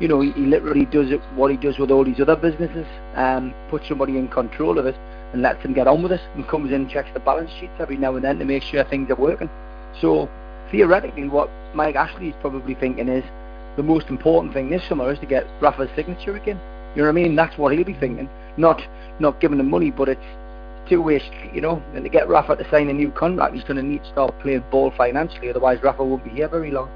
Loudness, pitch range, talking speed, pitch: -20 LUFS, 130-155 Hz, 250 wpm, 140 Hz